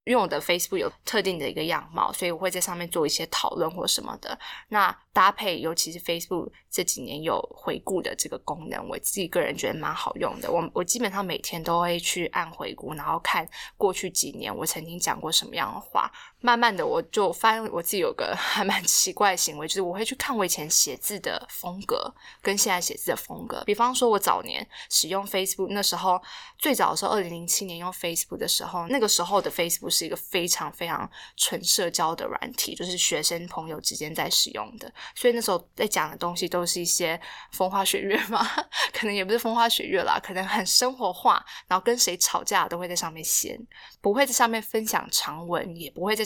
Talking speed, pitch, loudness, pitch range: 365 characters per minute, 185 Hz, -25 LUFS, 175-225 Hz